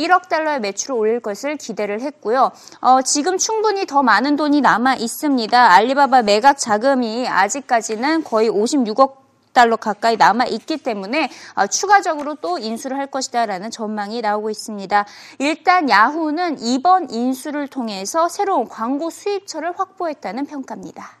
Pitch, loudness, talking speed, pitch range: 270 Hz, -17 LUFS, 340 characters per minute, 225-315 Hz